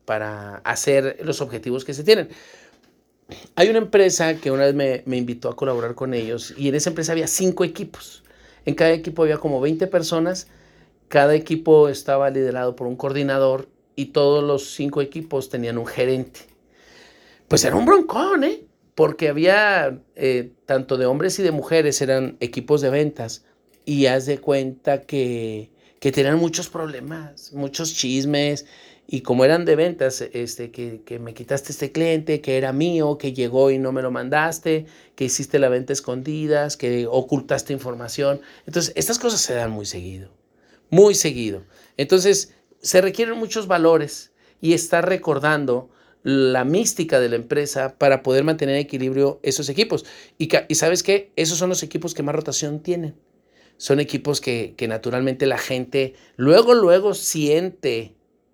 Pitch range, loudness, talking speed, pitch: 130-165 Hz, -20 LUFS, 165 wpm, 145 Hz